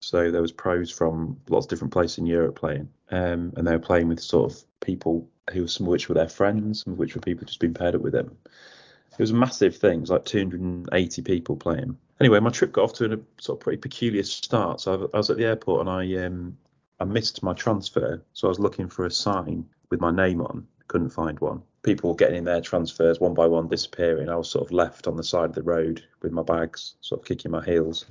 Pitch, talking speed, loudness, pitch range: 90 Hz, 250 wpm, -25 LUFS, 85-95 Hz